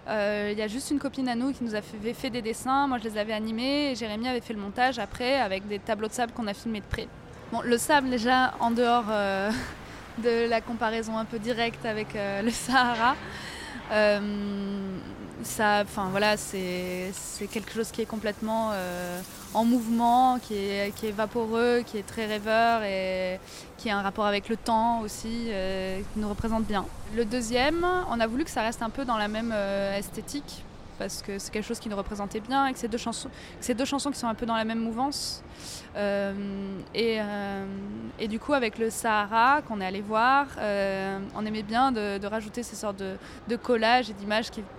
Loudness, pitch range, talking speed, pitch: -28 LUFS, 205-240 Hz, 210 wpm, 220 Hz